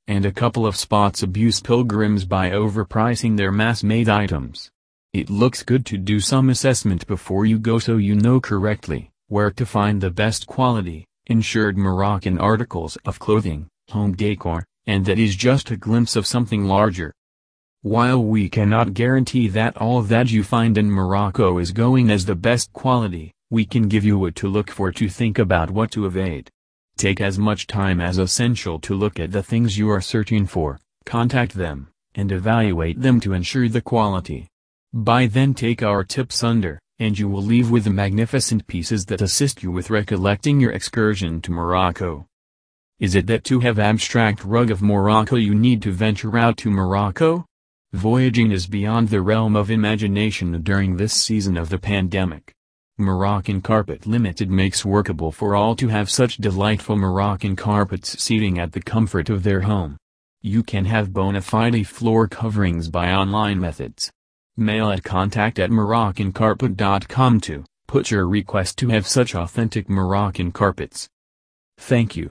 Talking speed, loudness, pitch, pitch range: 170 wpm, -19 LUFS, 105 Hz, 95-115 Hz